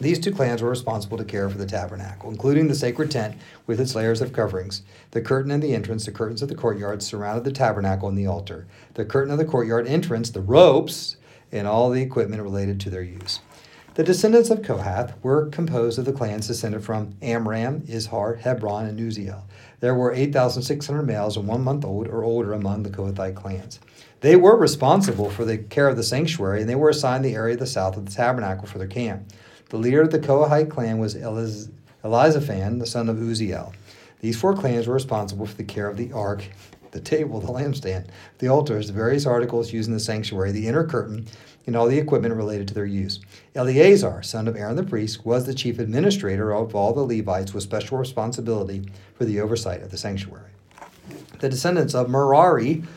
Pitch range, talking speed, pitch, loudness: 105-130 Hz, 205 wpm, 115 Hz, -22 LUFS